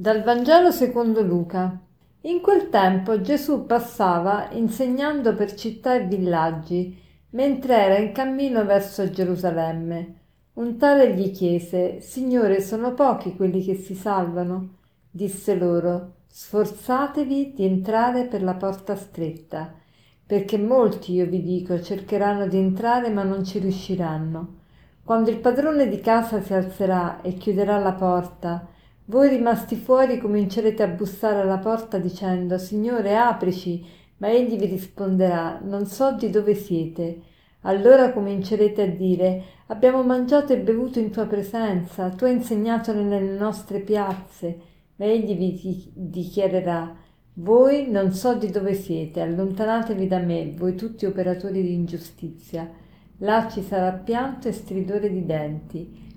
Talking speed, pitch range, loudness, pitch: 135 wpm, 180-225 Hz, -22 LUFS, 200 Hz